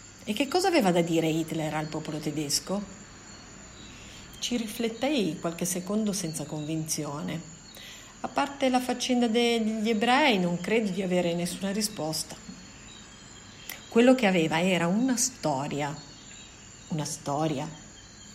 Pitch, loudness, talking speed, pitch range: 175 Hz, -27 LUFS, 120 wpm, 155-230 Hz